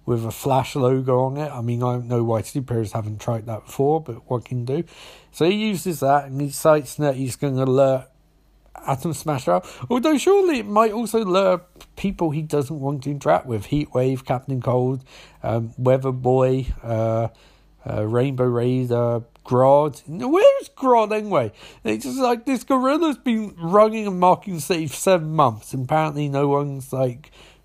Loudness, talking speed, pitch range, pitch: -21 LUFS, 185 wpm, 125-180 Hz, 140 Hz